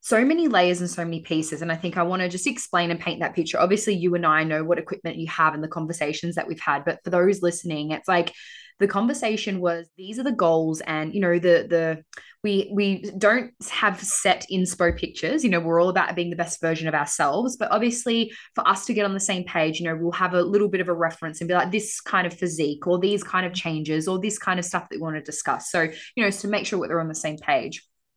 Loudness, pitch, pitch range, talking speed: -23 LUFS, 180 Hz, 165-200 Hz, 265 wpm